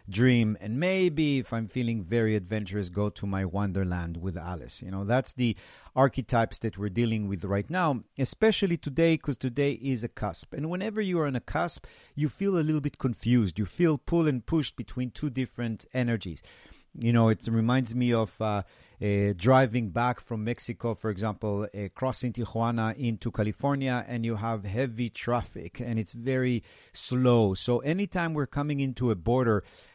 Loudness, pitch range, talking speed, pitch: -29 LUFS, 105-130 Hz, 180 wpm, 120 Hz